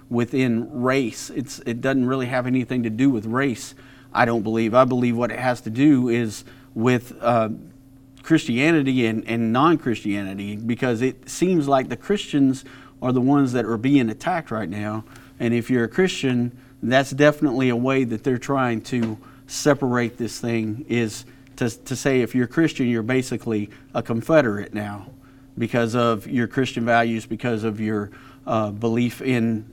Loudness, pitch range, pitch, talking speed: -22 LUFS, 115-135 Hz, 125 Hz, 170 wpm